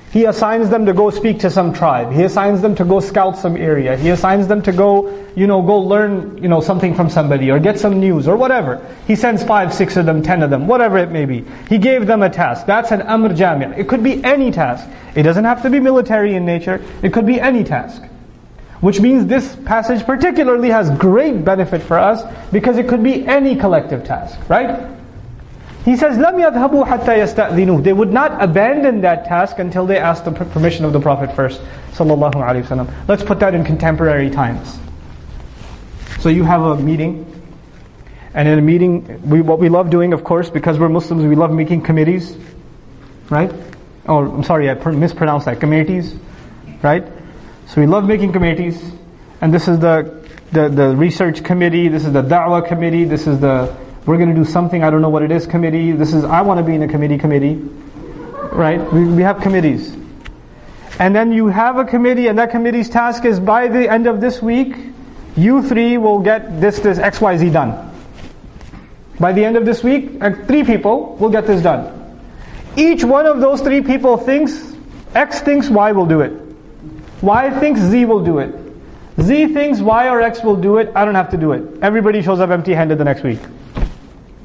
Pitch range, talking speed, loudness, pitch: 160-225 Hz, 200 wpm, -14 LUFS, 185 Hz